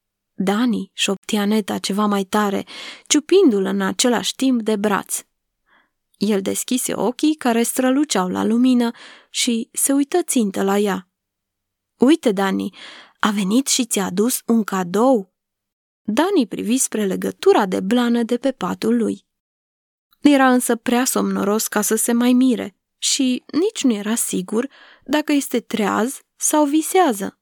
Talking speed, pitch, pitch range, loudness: 140 wpm, 235 Hz, 200-265 Hz, -19 LUFS